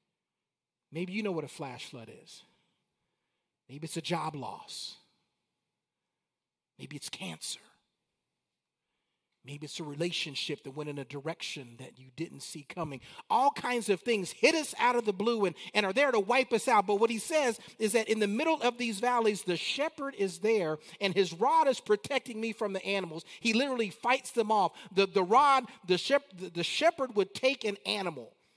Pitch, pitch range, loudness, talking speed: 200 Hz, 165-240 Hz, -30 LUFS, 190 wpm